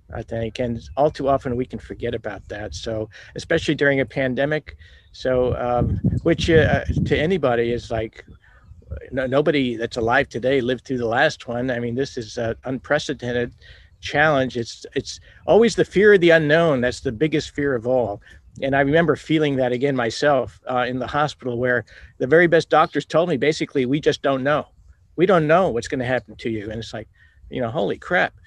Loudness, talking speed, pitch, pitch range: -21 LUFS, 200 wpm, 125 Hz, 115-145 Hz